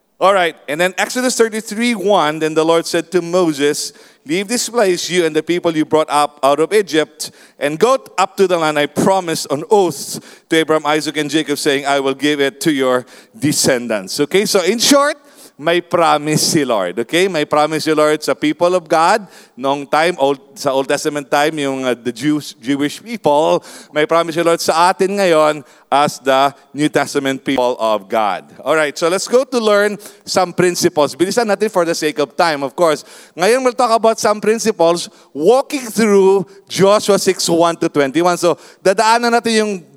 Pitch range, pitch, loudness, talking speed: 150-195 Hz, 170 Hz, -15 LUFS, 195 wpm